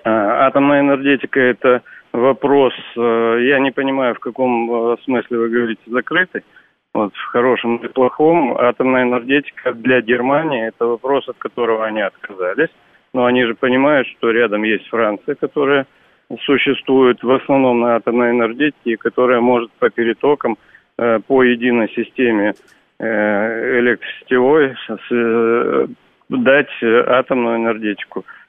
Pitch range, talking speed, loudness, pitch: 115-130 Hz, 115 wpm, -16 LUFS, 125 Hz